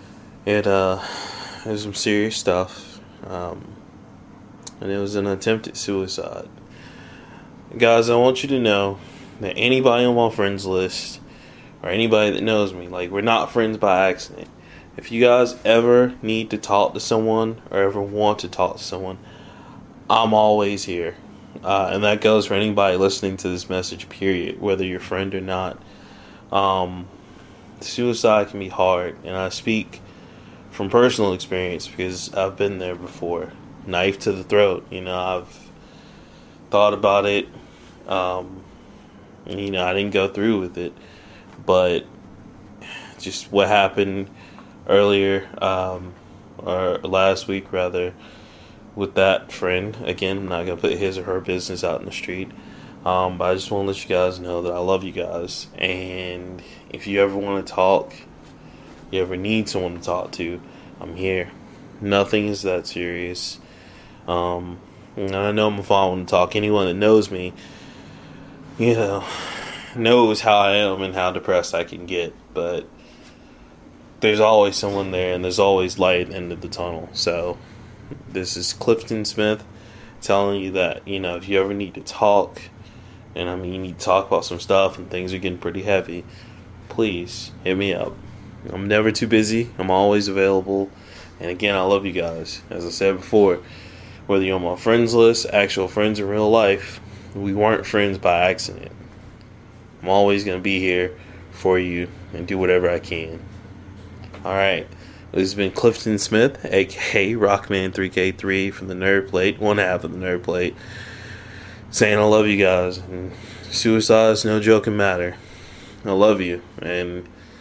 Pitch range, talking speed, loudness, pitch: 90-105 Hz, 165 wpm, -20 LUFS, 100 Hz